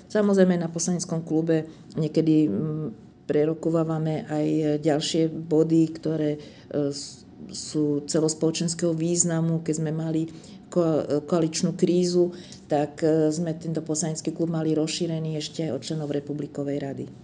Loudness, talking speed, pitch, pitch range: -25 LUFS, 110 wpm, 160 Hz, 155-165 Hz